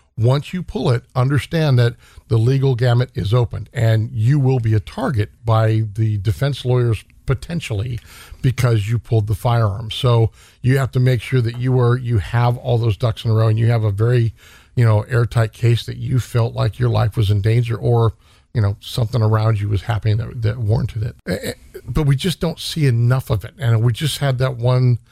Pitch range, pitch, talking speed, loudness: 110-125 Hz, 120 Hz, 210 wpm, -18 LUFS